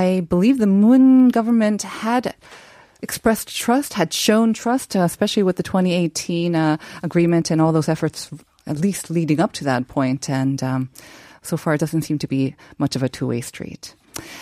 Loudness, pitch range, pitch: -19 LUFS, 150-210 Hz, 170 Hz